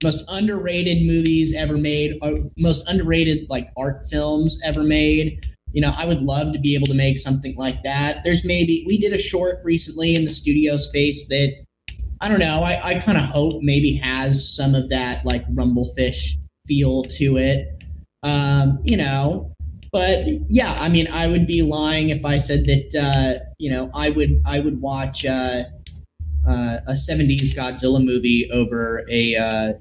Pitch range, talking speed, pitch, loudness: 130-155 Hz, 175 wpm, 145 Hz, -19 LUFS